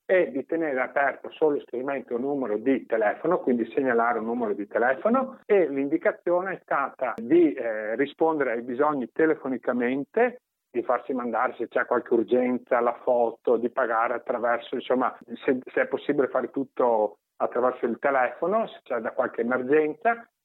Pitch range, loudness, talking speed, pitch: 125-170 Hz, -26 LUFS, 155 wpm, 140 Hz